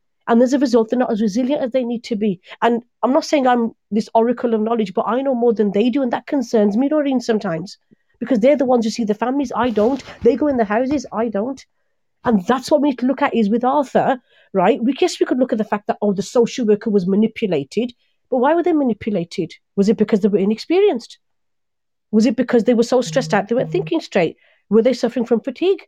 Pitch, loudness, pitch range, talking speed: 240 Hz, -18 LUFS, 220-265 Hz, 245 wpm